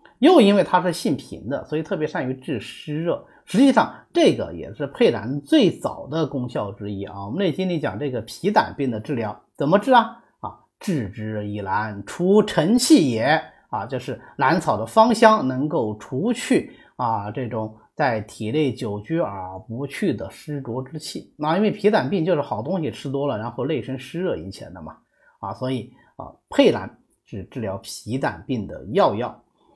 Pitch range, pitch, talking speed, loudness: 115-190 Hz, 145 Hz, 260 characters per minute, -22 LUFS